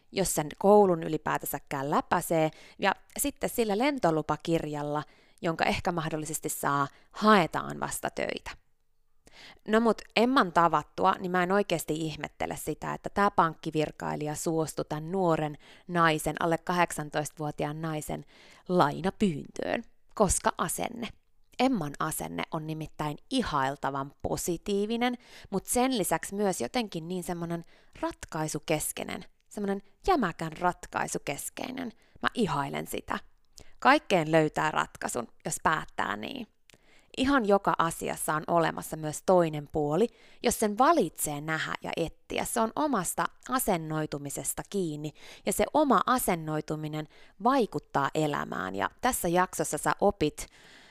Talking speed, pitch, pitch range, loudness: 110 wpm, 170 Hz, 155-205 Hz, -29 LUFS